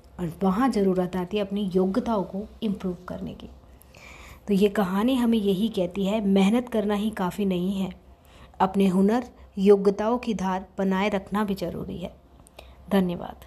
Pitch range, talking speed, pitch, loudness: 190-210 Hz, 155 wpm, 200 Hz, -25 LUFS